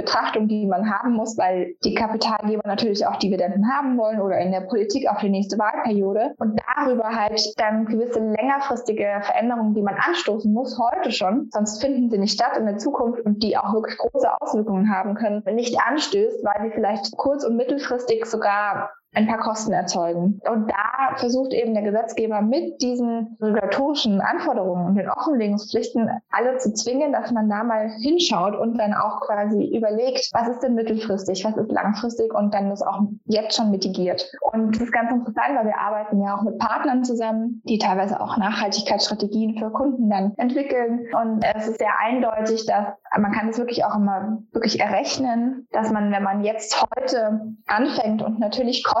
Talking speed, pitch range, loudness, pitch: 185 wpm, 205-240 Hz, -22 LUFS, 220 Hz